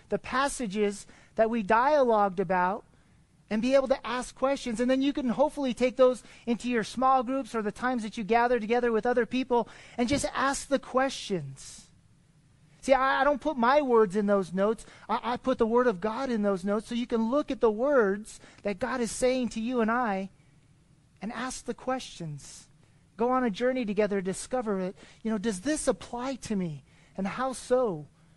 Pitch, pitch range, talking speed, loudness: 235 Hz, 200-255 Hz, 200 wpm, -28 LUFS